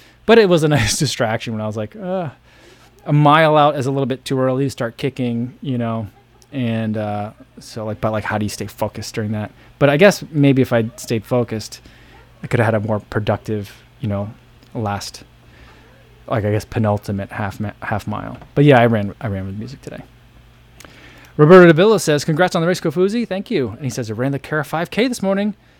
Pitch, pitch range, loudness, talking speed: 125 Hz, 110-145 Hz, -17 LUFS, 220 wpm